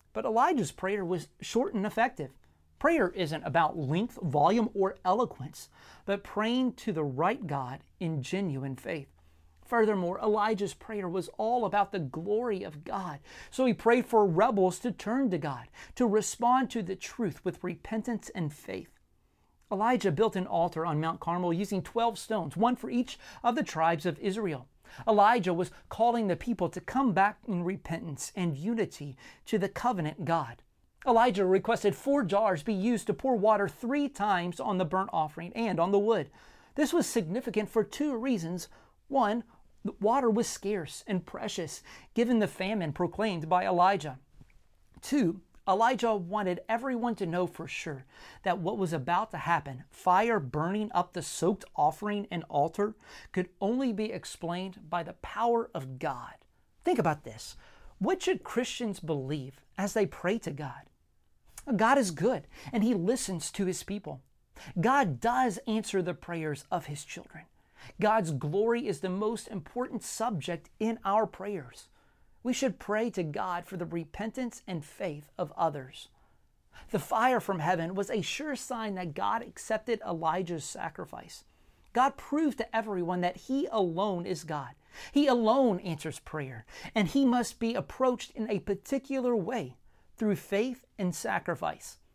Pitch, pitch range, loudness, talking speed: 200 Hz, 170-230 Hz, -31 LUFS, 160 wpm